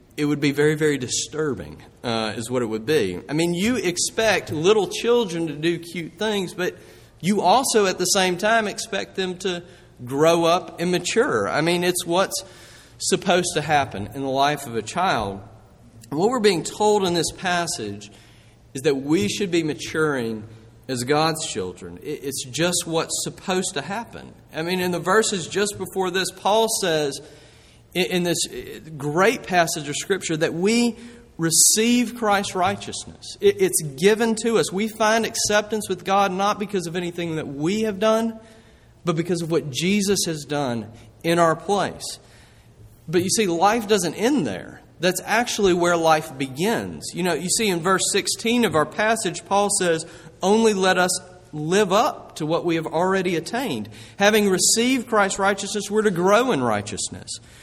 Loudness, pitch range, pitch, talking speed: -21 LUFS, 150-205 Hz, 175 Hz, 170 wpm